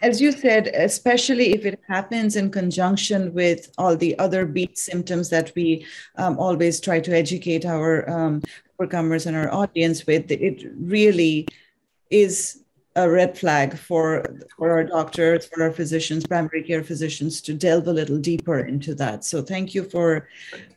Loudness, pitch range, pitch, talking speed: -21 LUFS, 160-185 Hz, 170 Hz, 160 wpm